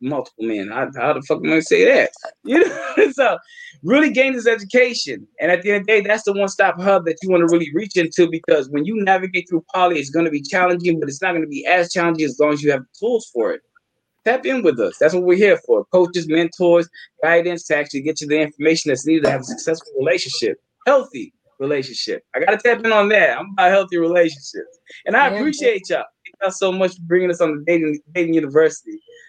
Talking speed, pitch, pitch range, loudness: 230 wpm, 180 Hz, 165-265 Hz, -17 LUFS